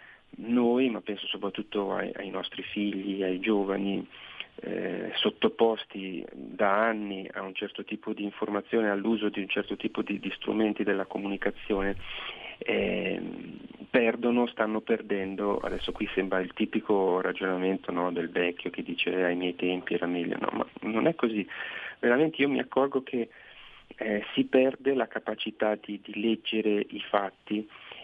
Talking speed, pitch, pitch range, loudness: 150 wpm, 105 Hz, 95-110 Hz, -29 LUFS